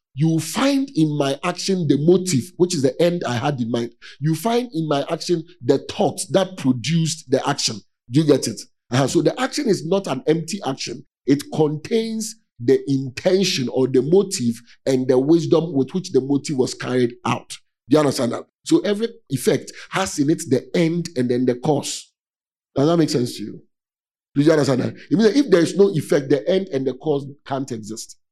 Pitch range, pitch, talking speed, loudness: 130-180 Hz, 150 Hz, 200 wpm, -20 LUFS